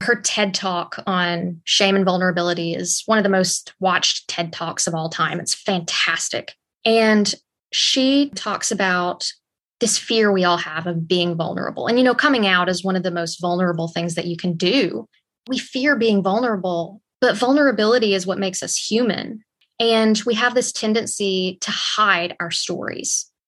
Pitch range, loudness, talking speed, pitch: 175-225 Hz, -19 LUFS, 175 wpm, 190 Hz